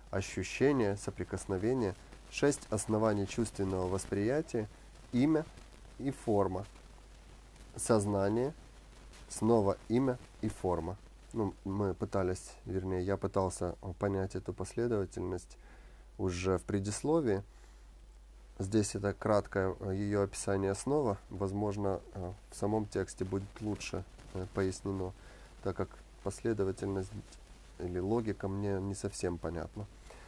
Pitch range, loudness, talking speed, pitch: 95-105 Hz, -35 LUFS, 95 wpm, 100 Hz